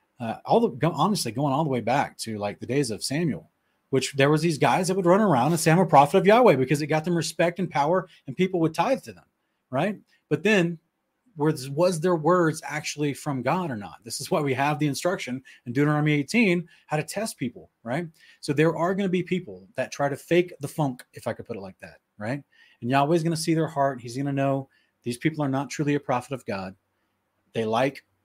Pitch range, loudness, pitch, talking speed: 135-175 Hz, -25 LUFS, 150 Hz, 245 wpm